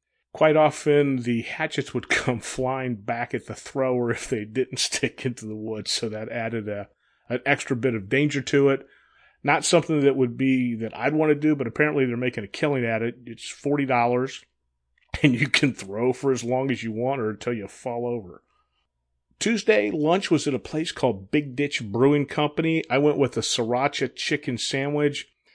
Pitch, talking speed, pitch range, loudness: 130 Hz, 195 wpm, 120-145 Hz, -24 LUFS